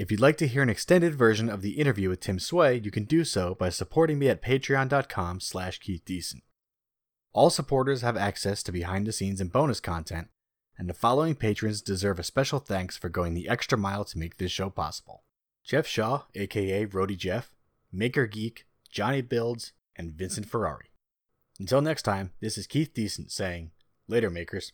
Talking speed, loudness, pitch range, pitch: 180 wpm, -28 LUFS, 95-125 Hz, 100 Hz